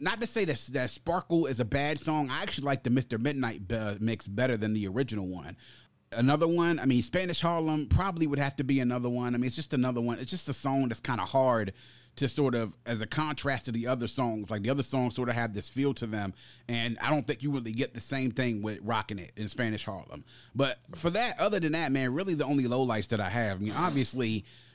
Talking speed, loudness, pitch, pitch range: 250 wpm, -30 LUFS, 125 Hz, 115-145 Hz